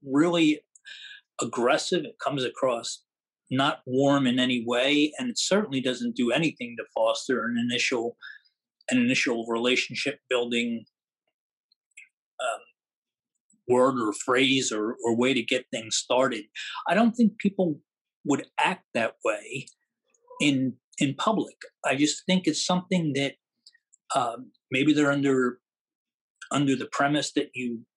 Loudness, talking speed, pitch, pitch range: -26 LUFS, 130 wpm, 140 Hz, 125-185 Hz